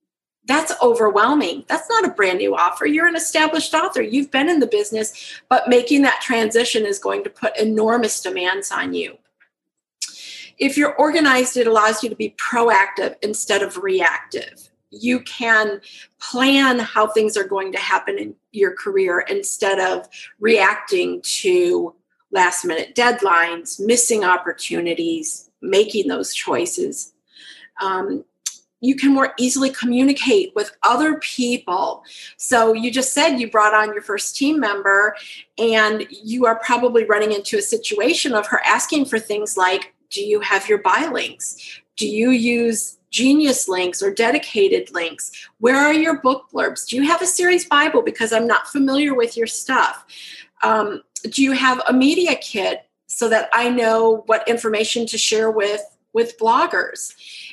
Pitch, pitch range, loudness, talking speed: 245 Hz, 215-305 Hz, -18 LUFS, 155 wpm